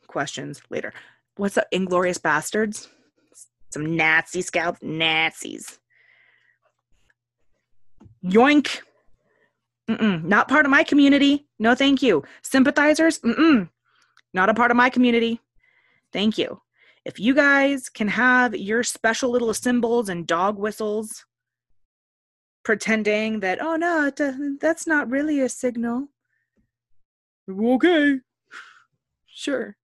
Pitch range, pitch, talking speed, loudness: 200-285 Hz, 240 Hz, 110 wpm, -21 LUFS